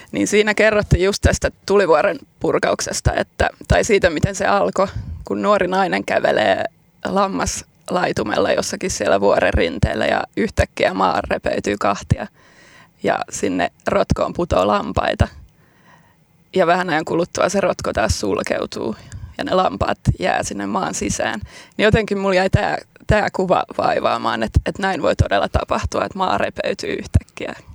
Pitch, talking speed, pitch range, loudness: 195 Hz, 140 wpm, 180-210 Hz, -19 LUFS